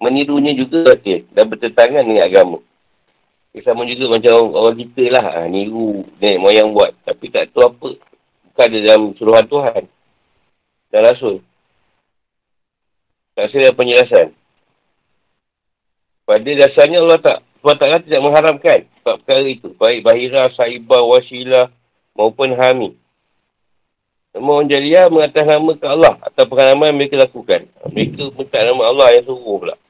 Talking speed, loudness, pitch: 145 wpm, -12 LUFS, 155 Hz